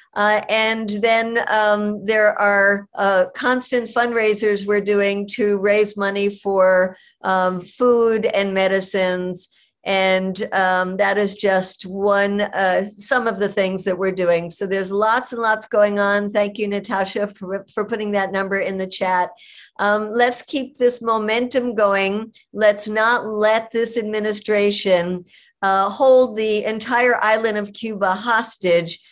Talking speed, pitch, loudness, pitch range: 145 wpm, 205 Hz, -19 LUFS, 195-220 Hz